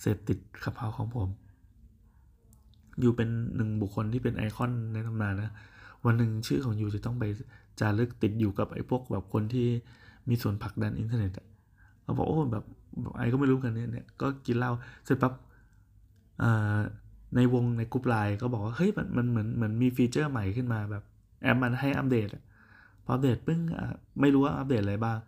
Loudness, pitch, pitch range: -30 LUFS, 115 Hz, 105-125 Hz